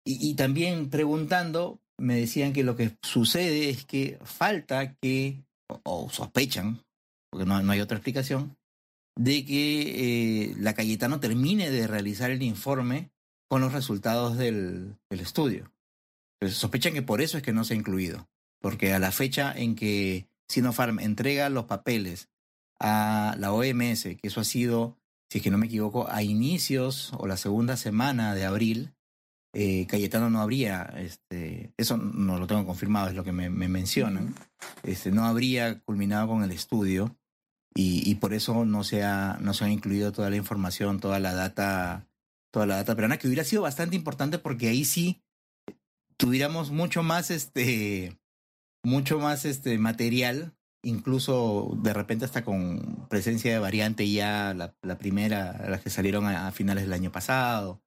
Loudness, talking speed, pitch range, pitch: -28 LUFS, 170 wpm, 100-130 Hz, 110 Hz